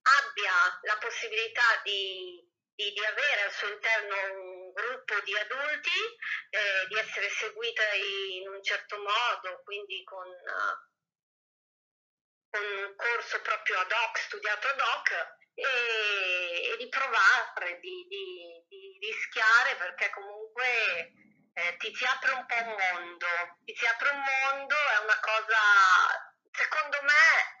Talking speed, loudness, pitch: 135 wpm, -28 LUFS, 230 Hz